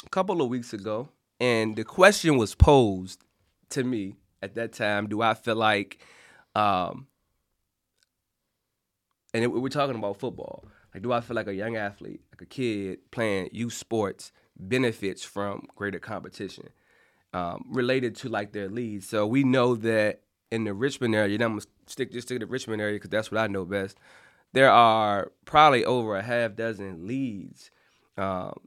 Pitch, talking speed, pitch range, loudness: 110 Hz, 175 wpm, 100-120 Hz, -26 LUFS